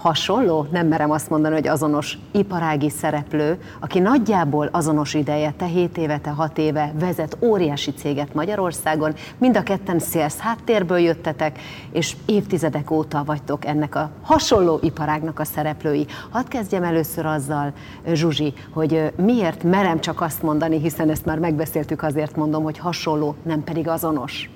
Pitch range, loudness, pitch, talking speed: 150-170 Hz, -21 LUFS, 155 Hz, 150 wpm